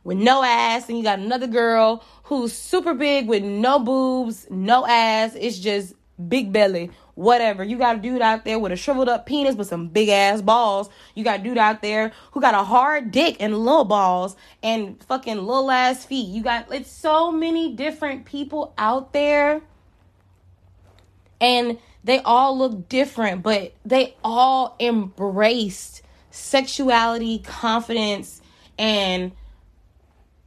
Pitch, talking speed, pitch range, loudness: 230 Hz, 150 wpm, 200-260 Hz, -20 LUFS